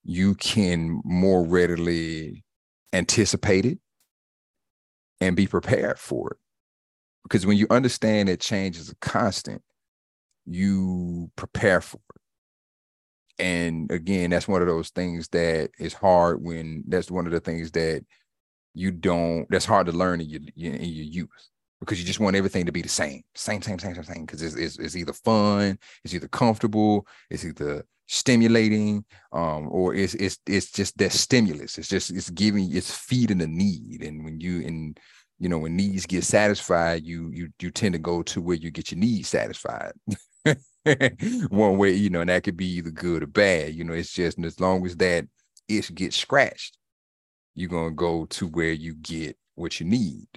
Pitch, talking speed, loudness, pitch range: 90 Hz, 180 wpm, -24 LUFS, 85-100 Hz